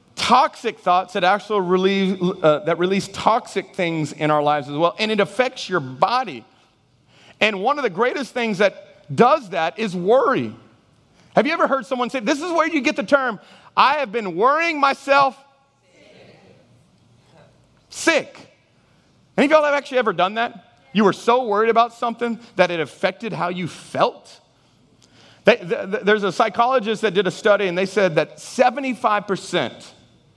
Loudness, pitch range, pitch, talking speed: -19 LUFS, 185-255 Hz, 210 Hz, 160 wpm